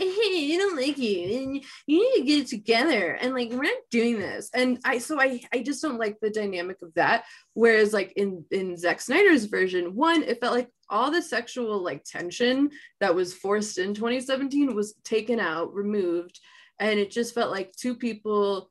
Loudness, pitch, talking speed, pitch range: -25 LUFS, 235 Hz, 200 wpm, 200-270 Hz